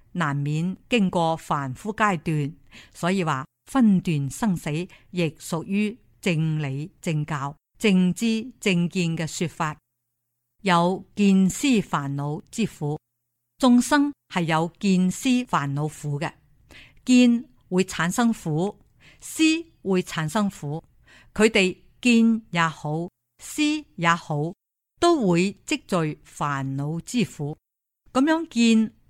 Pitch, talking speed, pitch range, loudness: 175 Hz, 155 characters per minute, 150-215 Hz, -24 LUFS